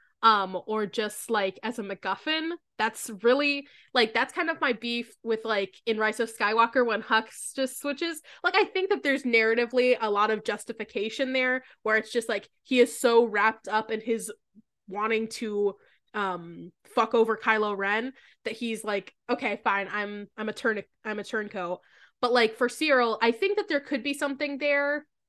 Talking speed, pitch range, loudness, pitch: 185 wpm, 215-260 Hz, -27 LUFS, 230 Hz